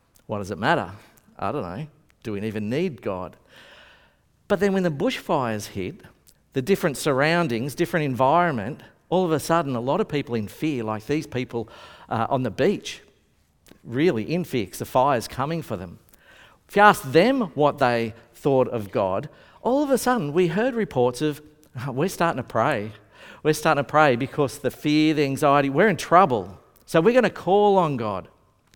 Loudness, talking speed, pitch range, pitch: -23 LUFS, 185 wpm, 115-170 Hz, 145 Hz